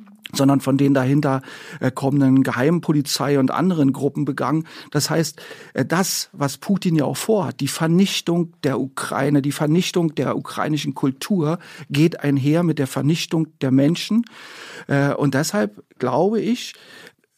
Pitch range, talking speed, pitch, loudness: 140-170 Hz, 130 wpm, 150 Hz, -20 LUFS